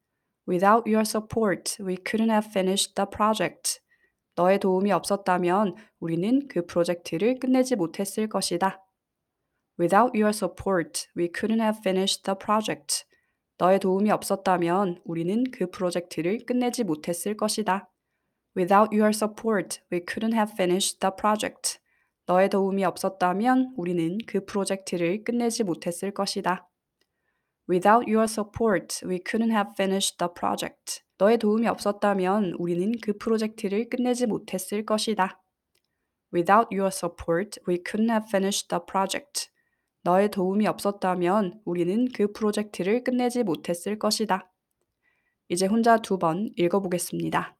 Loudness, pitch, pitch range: -25 LUFS, 195 Hz, 185-220 Hz